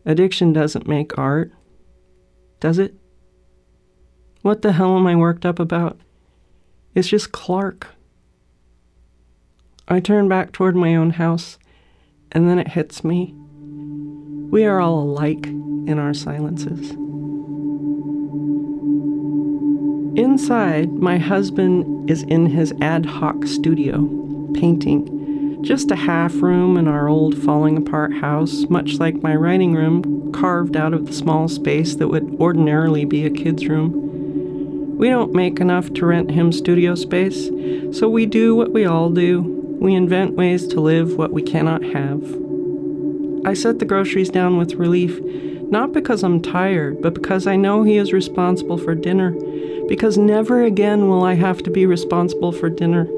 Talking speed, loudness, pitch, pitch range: 145 wpm, -18 LUFS, 165 Hz, 145-185 Hz